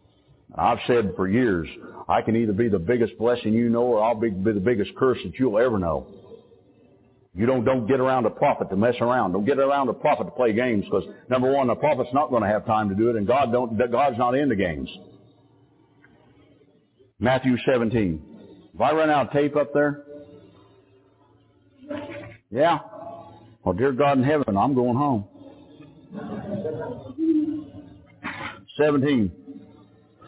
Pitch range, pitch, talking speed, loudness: 110-145 Hz, 125 Hz, 165 wpm, -23 LUFS